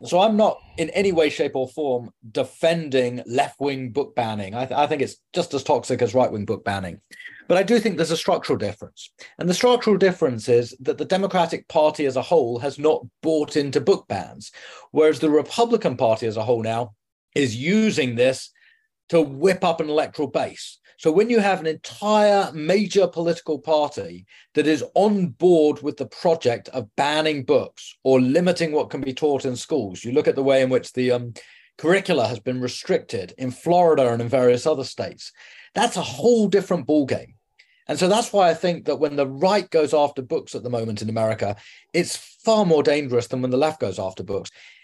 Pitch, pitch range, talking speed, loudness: 150 Hz, 125-175 Hz, 200 wpm, -21 LUFS